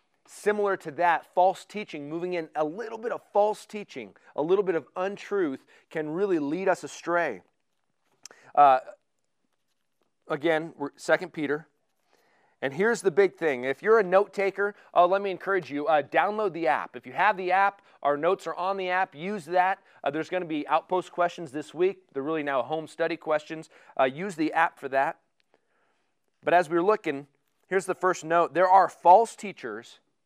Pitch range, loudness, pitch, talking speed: 155-195 Hz, -26 LUFS, 180 Hz, 180 wpm